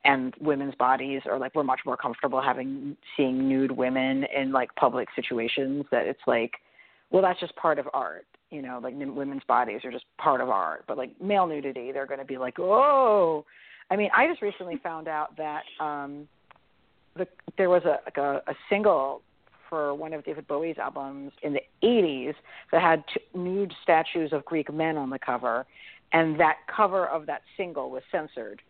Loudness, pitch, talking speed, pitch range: -27 LUFS, 145 Hz, 190 wpm, 135-165 Hz